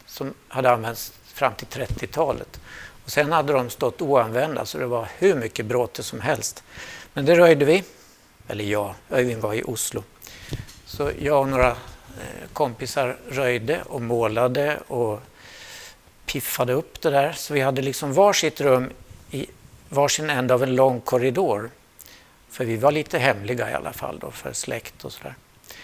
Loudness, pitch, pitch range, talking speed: -23 LUFS, 125 Hz, 120-145 Hz, 160 wpm